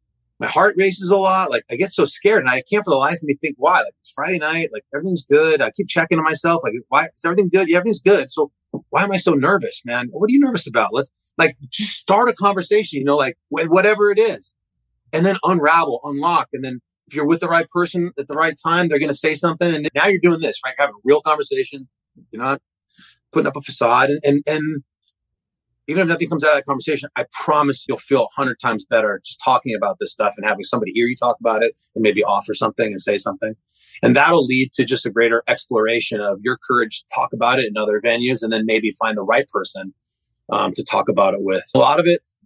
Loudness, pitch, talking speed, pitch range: -18 LUFS, 155 Hz, 250 wpm, 135-185 Hz